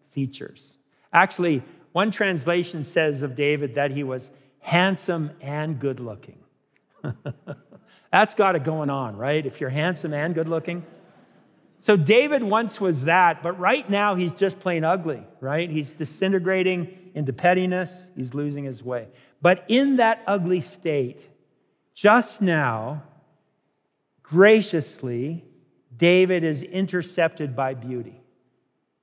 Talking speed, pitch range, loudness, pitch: 125 wpm, 140-185 Hz, -22 LUFS, 165 Hz